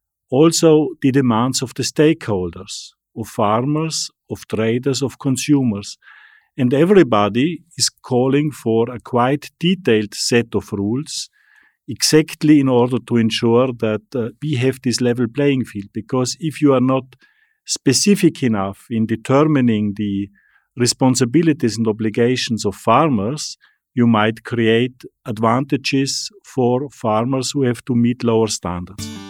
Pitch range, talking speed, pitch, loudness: 110-145 Hz, 130 wpm, 125 Hz, -17 LUFS